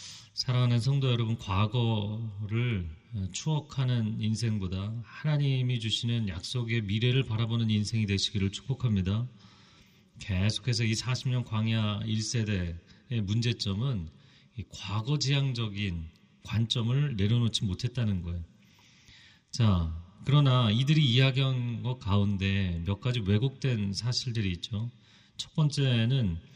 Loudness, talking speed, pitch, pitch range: -29 LUFS, 260 characters per minute, 110 Hz, 100-125 Hz